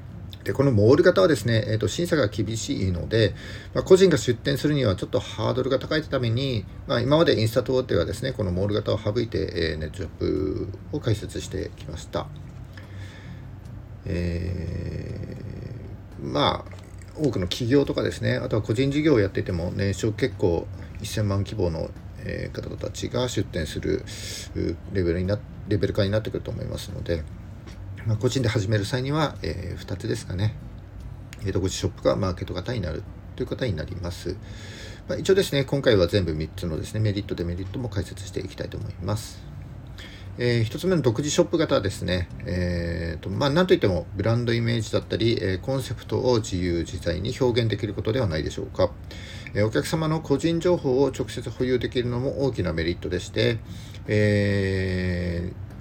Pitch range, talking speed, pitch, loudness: 95-125 Hz, 370 characters per minute, 105 Hz, -25 LUFS